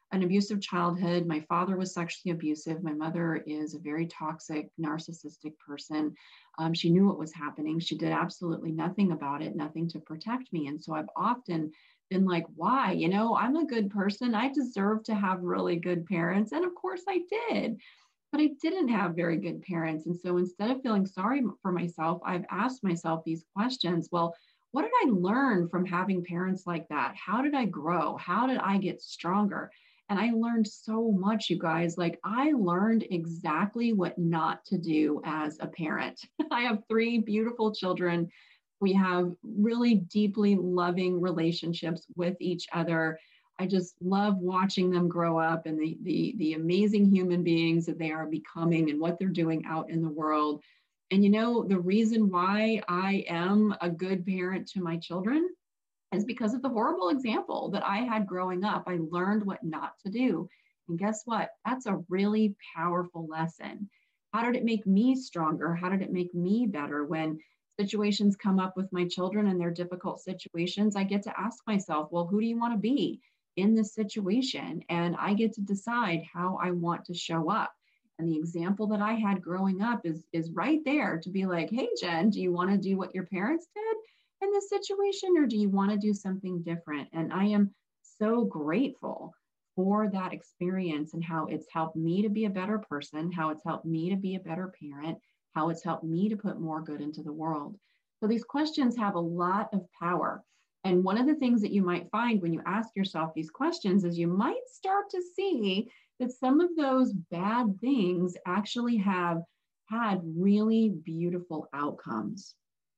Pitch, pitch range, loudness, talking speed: 185 Hz, 165-215 Hz, -30 LUFS, 190 wpm